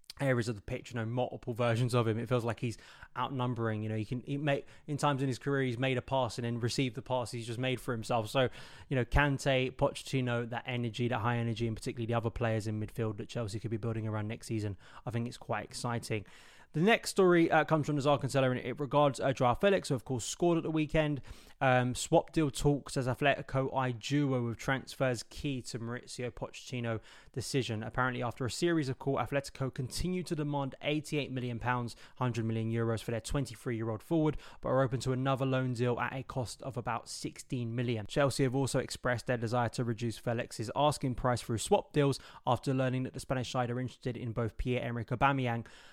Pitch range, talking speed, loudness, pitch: 115-135 Hz, 215 wpm, -33 LUFS, 125 Hz